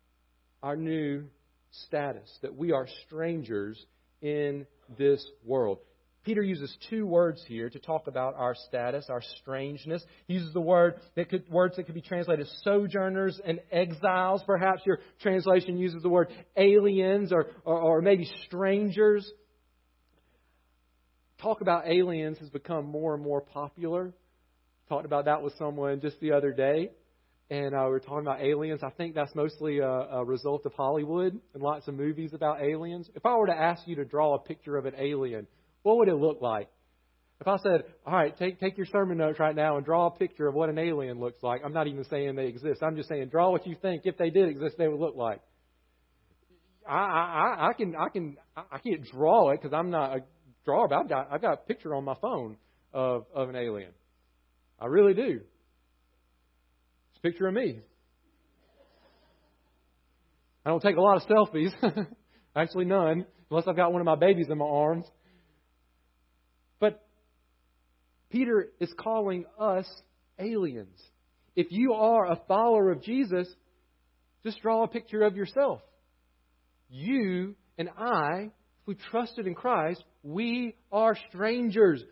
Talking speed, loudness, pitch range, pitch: 170 wpm, -29 LUFS, 125-185 Hz, 155 Hz